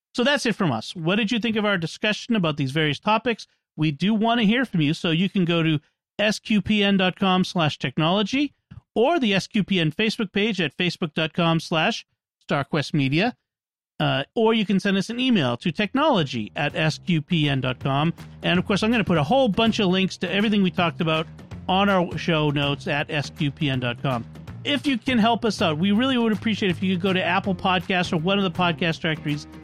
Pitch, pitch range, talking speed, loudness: 185 Hz, 155-215 Hz, 200 wpm, -22 LUFS